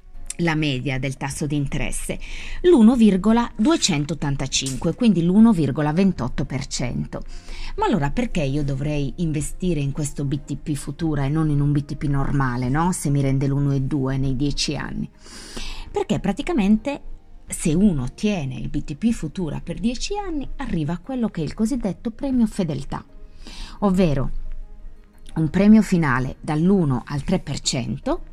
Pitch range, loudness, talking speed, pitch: 140-205 Hz, -22 LUFS, 125 wpm, 155 Hz